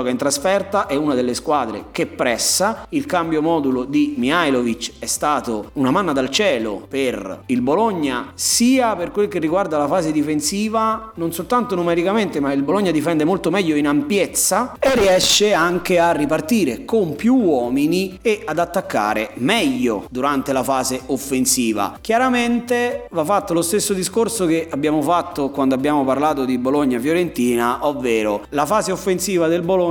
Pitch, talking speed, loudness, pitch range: 165 Hz, 155 wpm, -18 LUFS, 140-200 Hz